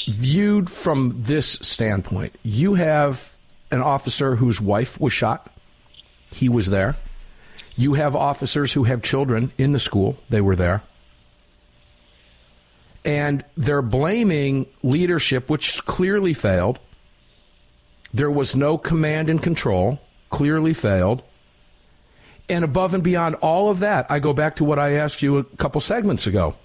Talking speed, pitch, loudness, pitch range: 135 wpm, 135 Hz, -20 LUFS, 95-150 Hz